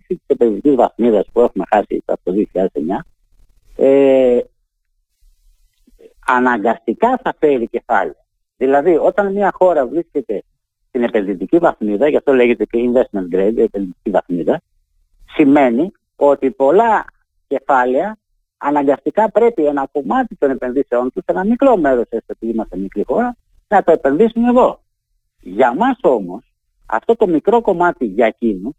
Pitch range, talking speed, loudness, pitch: 110-185 Hz, 130 wpm, -15 LUFS, 135 Hz